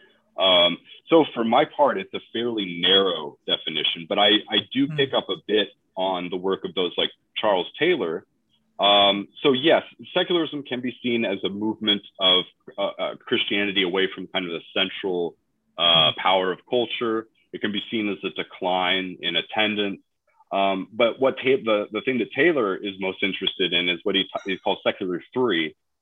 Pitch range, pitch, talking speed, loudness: 95-115 Hz, 100 Hz, 185 wpm, -22 LUFS